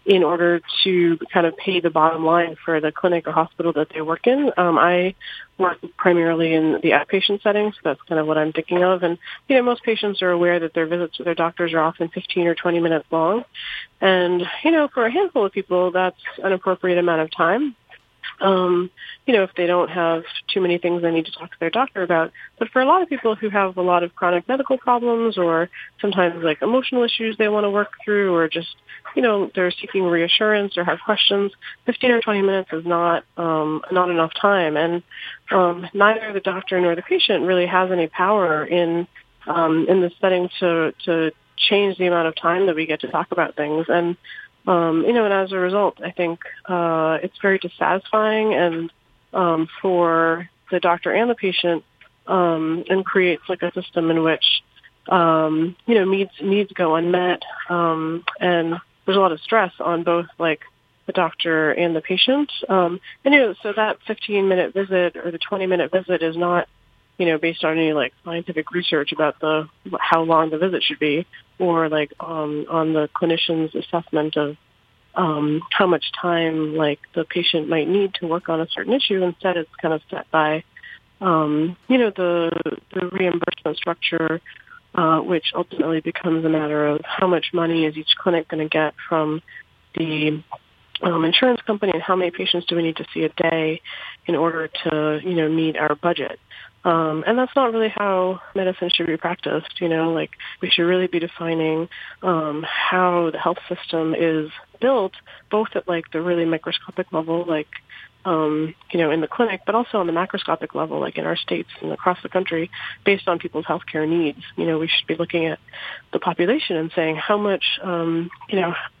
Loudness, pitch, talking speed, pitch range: -20 LUFS, 175 Hz, 200 wpm, 160-190 Hz